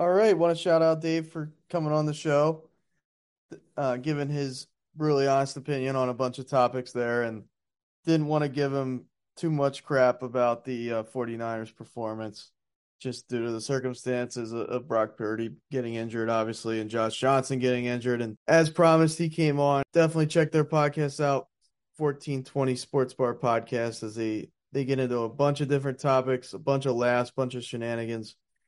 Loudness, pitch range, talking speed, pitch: -27 LUFS, 120-150 Hz, 185 wpm, 130 Hz